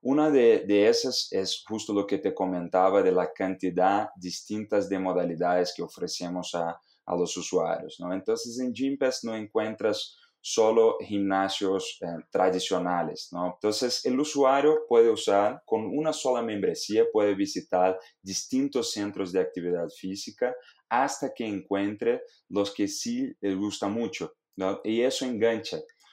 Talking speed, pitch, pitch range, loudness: 140 wpm, 105 Hz, 95-155 Hz, -27 LUFS